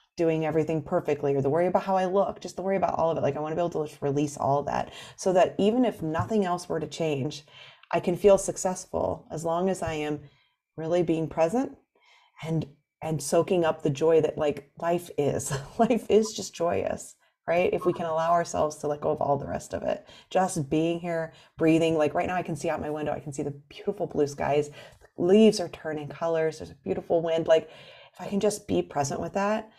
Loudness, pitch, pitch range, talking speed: -27 LUFS, 165 Hz, 150-180 Hz, 235 wpm